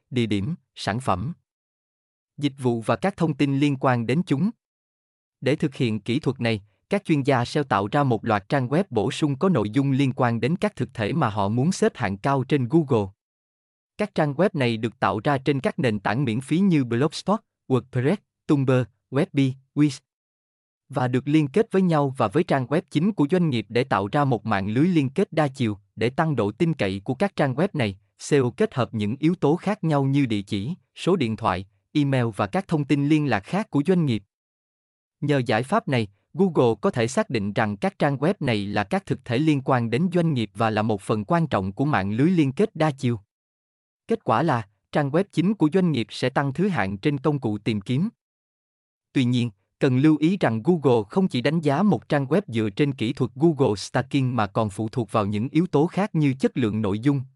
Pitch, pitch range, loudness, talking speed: 135 Hz, 110-155 Hz, -23 LUFS, 225 wpm